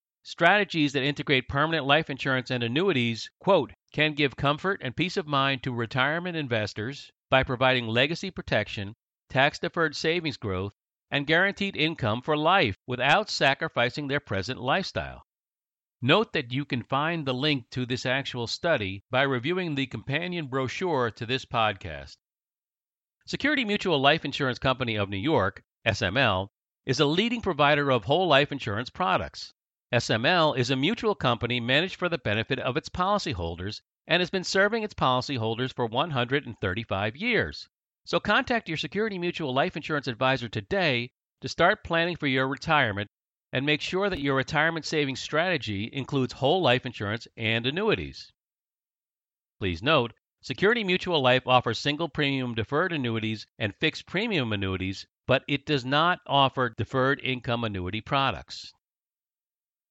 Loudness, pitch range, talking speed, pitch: -26 LUFS, 120-155 Hz, 145 wpm, 135 Hz